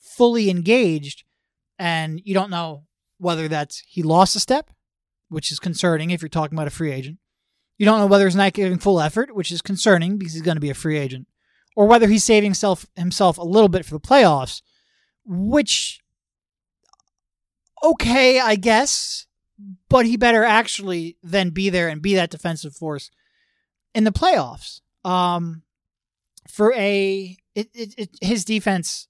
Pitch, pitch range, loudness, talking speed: 190 Hz, 165-220 Hz, -19 LUFS, 165 wpm